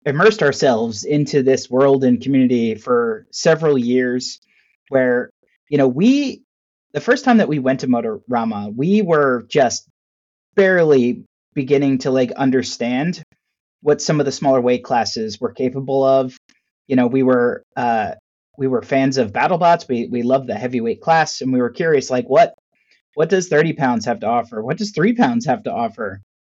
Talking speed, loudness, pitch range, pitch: 170 wpm, -17 LUFS, 125-155 Hz, 135 Hz